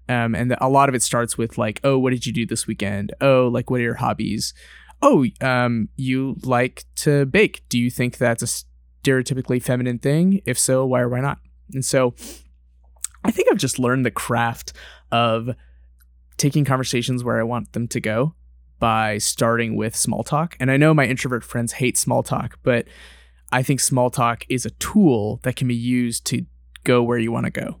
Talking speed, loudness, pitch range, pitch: 200 wpm, -20 LUFS, 110-130 Hz, 120 Hz